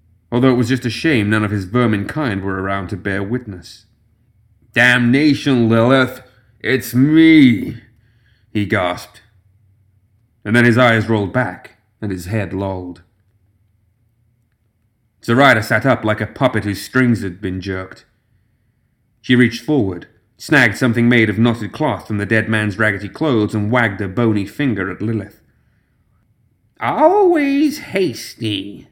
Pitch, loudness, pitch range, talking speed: 110 Hz, -16 LUFS, 105-125 Hz, 140 wpm